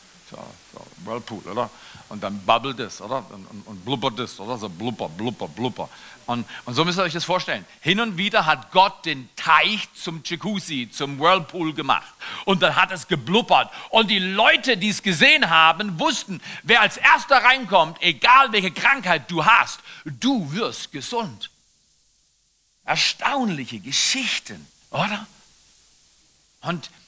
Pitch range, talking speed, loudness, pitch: 145-215 Hz, 150 wpm, -20 LUFS, 180 Hz